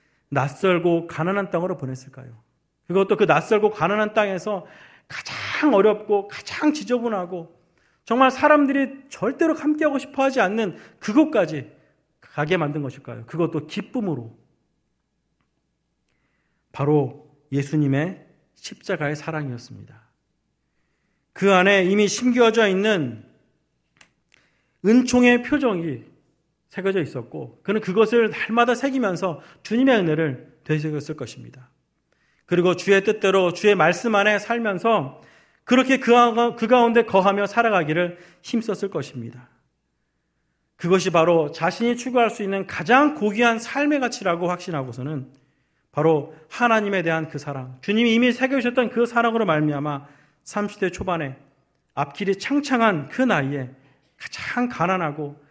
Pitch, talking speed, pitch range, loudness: 185 Hz, 285 characters per minute, 150-230 Hz, -21 LUFS